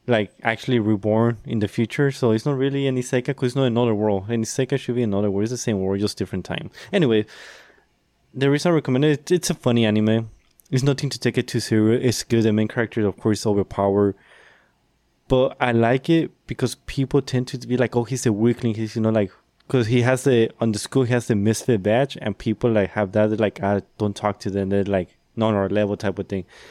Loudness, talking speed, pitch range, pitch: -22 LUFS, 235 wpm, 105-130 Hz, 115 Hz